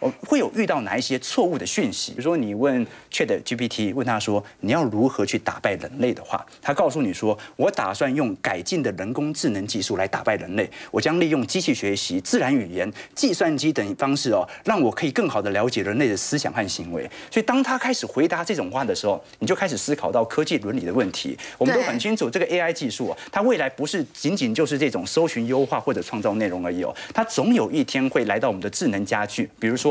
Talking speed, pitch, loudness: 360 characters per minute, 150 Hz, -23 LUFS